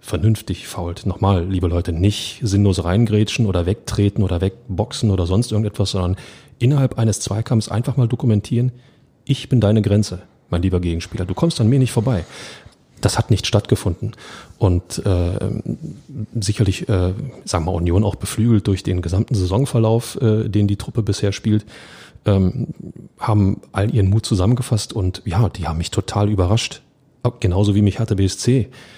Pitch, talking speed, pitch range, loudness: 105 Hz, 160 wpm, 95-115 Hz, -19 LUFS